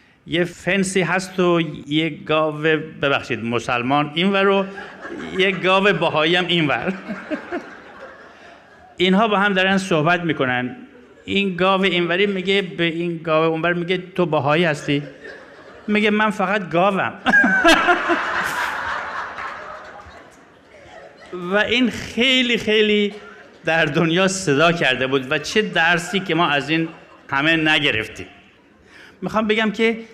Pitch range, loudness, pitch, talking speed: 160-200 Hz, -18 LUFS, 180 Hz, 115 wpm